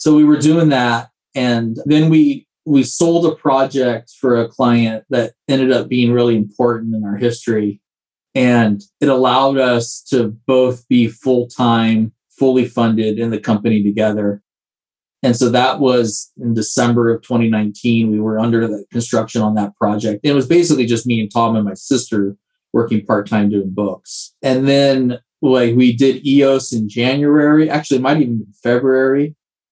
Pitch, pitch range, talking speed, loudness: 120 Hz, 110-135 Hz, 170 wpm, -15 LUFS